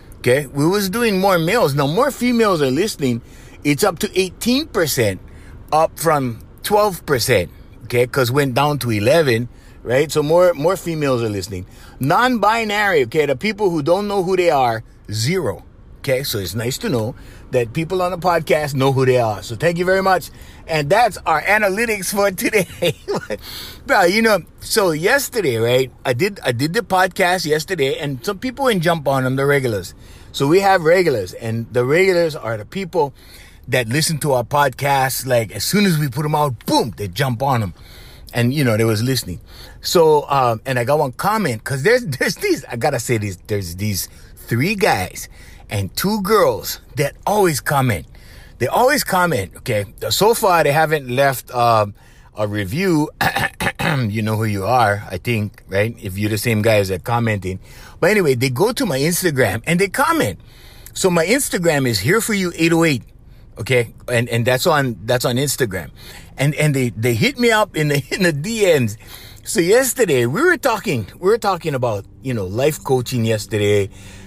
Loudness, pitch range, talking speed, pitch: -18 LUFS, 115-175 Hz, 185 wpm, 135 Hz